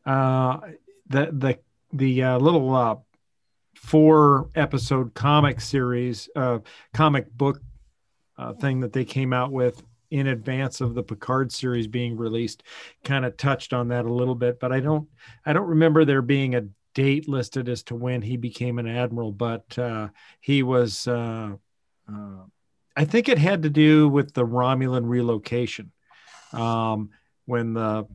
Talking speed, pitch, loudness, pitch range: 160 wpm, 125 Hz, -23 LUFS, 120-140 Hz